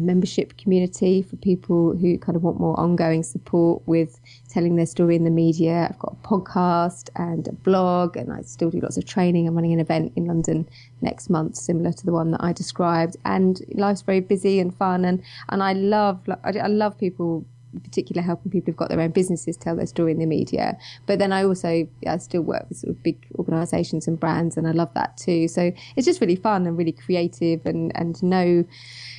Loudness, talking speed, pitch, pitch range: -22 LUFS, 215 wpm, 170 Hz, 165-185 Hz